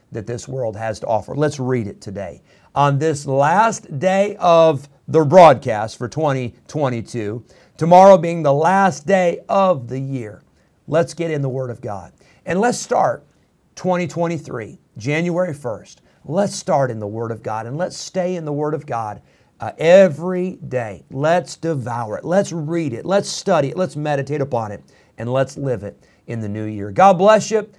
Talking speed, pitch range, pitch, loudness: 175 wpm, 120-175 Hz, 145 Hz, -18 LUFS